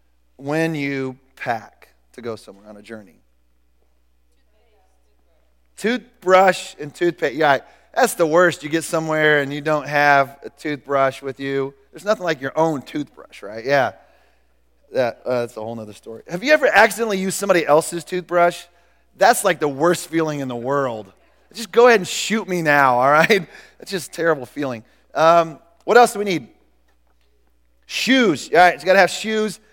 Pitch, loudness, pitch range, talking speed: 150 Hz, -18 LUFS, 115-180 Hz, 175 wpm